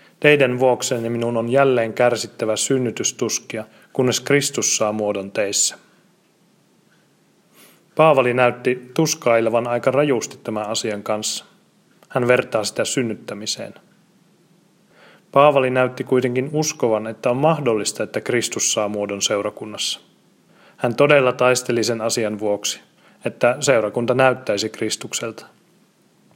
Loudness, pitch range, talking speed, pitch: -19 LUFS, 110-140 Hz, 105 wpm, 125 Hz